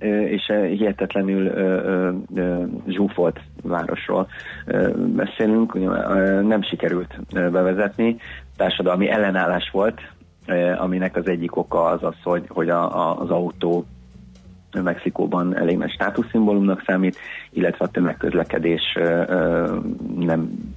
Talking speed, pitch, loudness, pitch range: 85 wpm, 90 Hz, -21 LUFS, 85-100 Hz